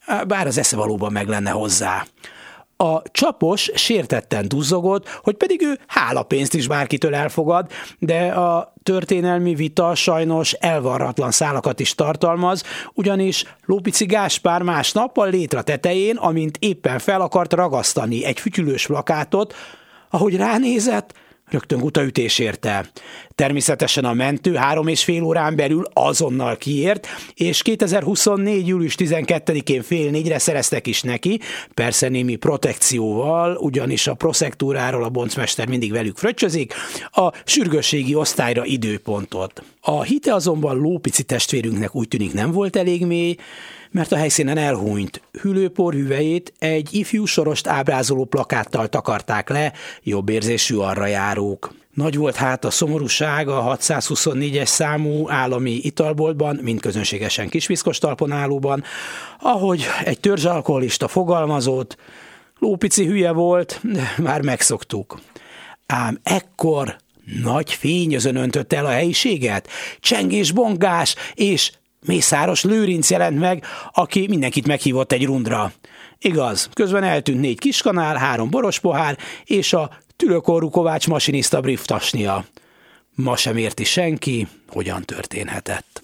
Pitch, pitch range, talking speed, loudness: 155 Hz, 130-180 Hz, 120 wpm, -19 LUFS